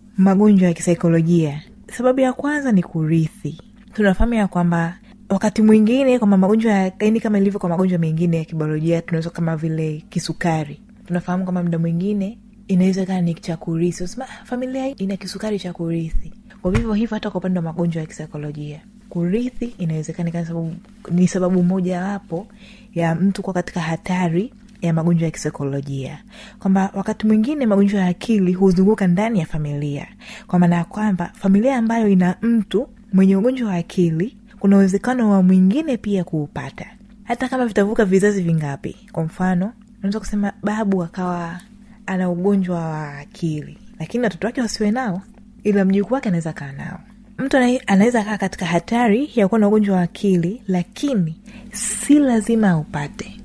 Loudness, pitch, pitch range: -19 LUFS, 195 Hz, 170-215 Hz